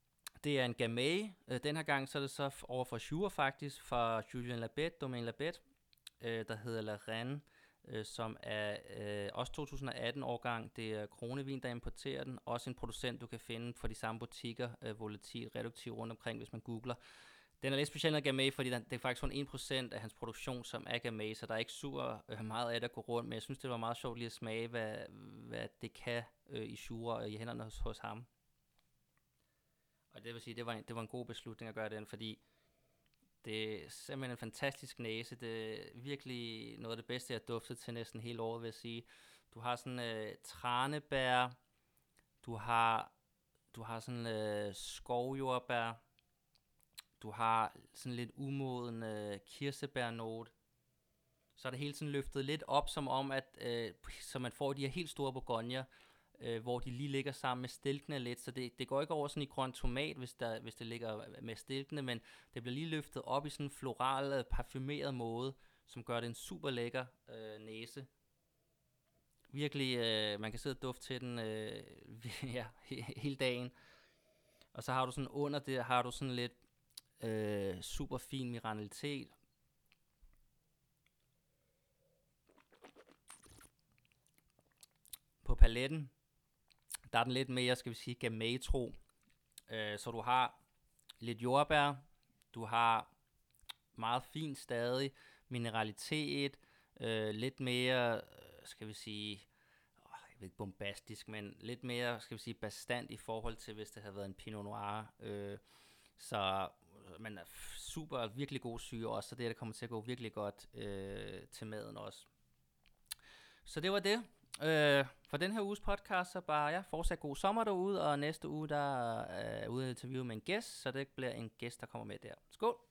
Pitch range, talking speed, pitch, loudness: 115-135 Hz, 180 wpm, 120 Hz, -41 LUFS